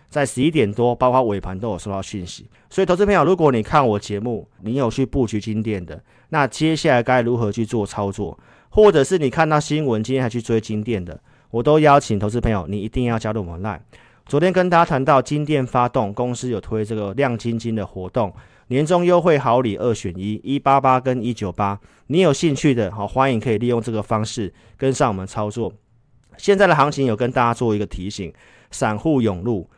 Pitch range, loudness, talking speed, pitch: 105-135 Hz, -19 LUFS, 320 characters per minute, 120 Hz